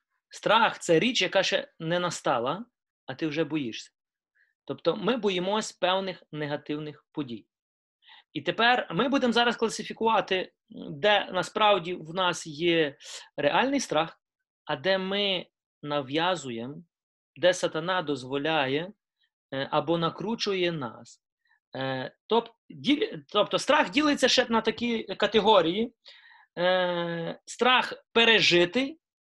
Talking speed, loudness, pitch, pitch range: 100 wpm, -26 LUFS, 185 Hz, 160-230 Hz